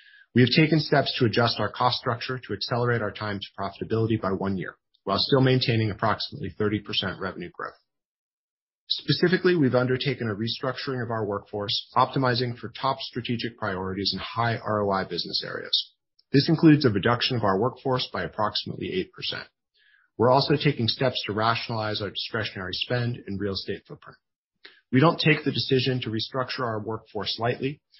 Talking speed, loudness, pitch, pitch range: 165 wpm, -25 LUFS, 120 Hz, 105-130 Hz